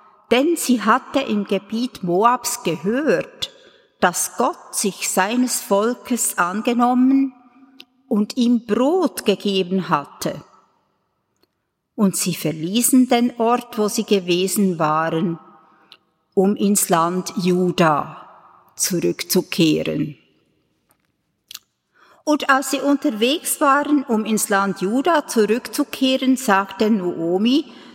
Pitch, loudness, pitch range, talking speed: 220 Hz, -19 LUFS, 185-255 Hz, 95 wpm